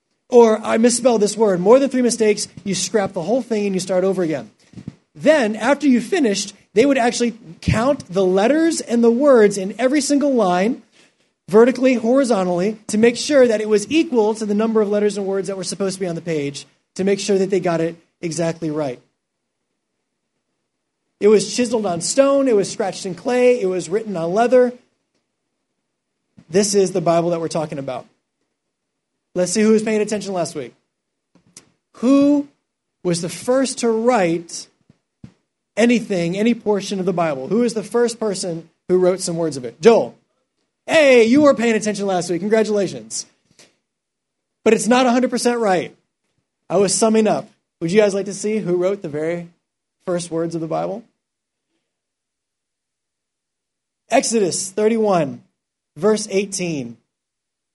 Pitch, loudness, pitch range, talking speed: 210 Hz, -18 LUFS, 180-235 Hz, 165 wpm